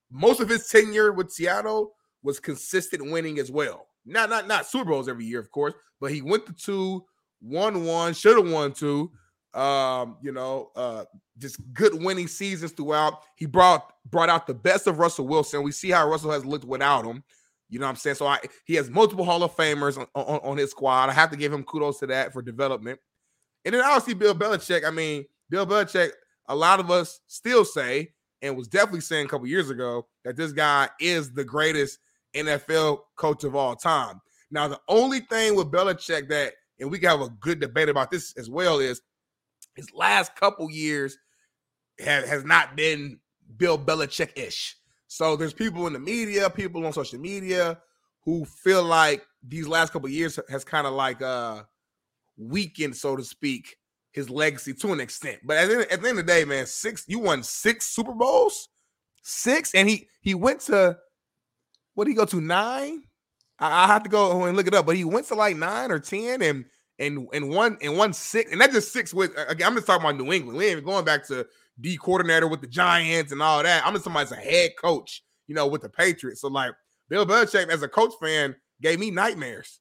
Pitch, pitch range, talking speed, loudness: 165 Hz, 145-200 Hz, 210 wpm, -24 LUFS